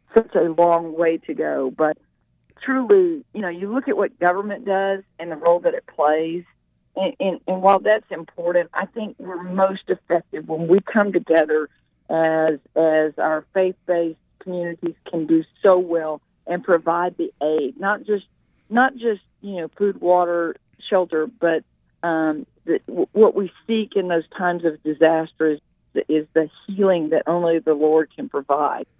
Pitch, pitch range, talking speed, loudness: 175 Hz, 160-195 Hz, 170 wpm, -21 LUFS